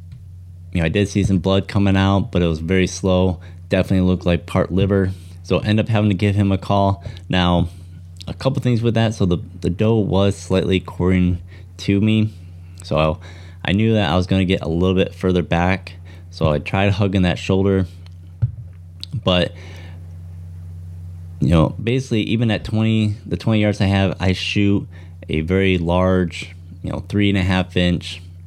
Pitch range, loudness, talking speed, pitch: 90-100 Hz, -19 LUFS, 185 wpm, 95 Hz